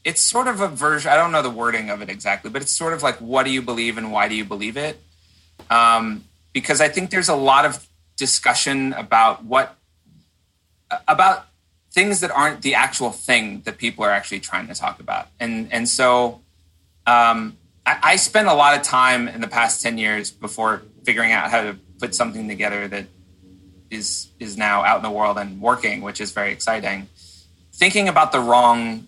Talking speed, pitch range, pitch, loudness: 200 wpm, 100-135 Hz, 115 Hz, -18 LUFS